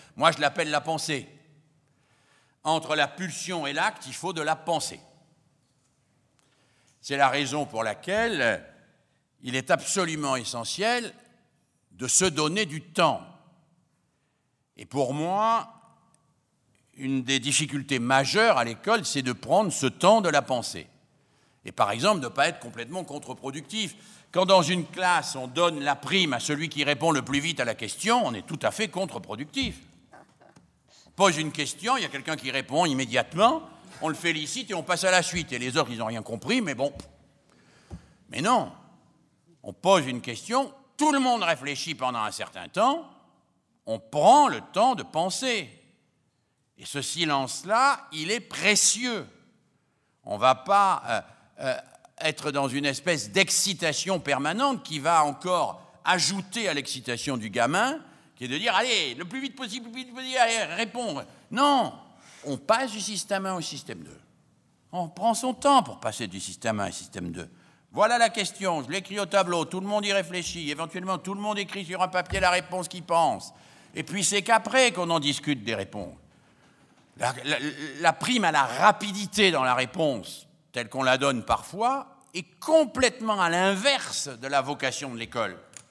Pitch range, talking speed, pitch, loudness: 140-200 Hz, 170 wpm, 165 Hz, -26 LUFS